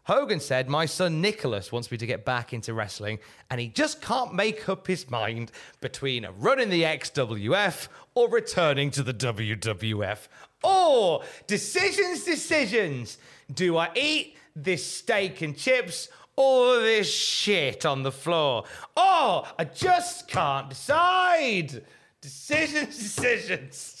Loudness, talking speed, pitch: -25 LUFS, 135 wpm, 180 Hz